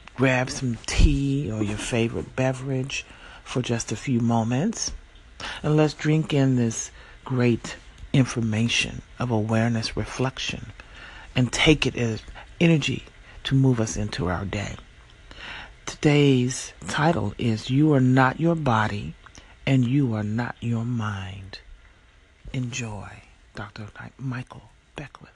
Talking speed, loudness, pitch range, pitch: 120 wpm, -24 LUFS, 110-130 Hz, 120 Hz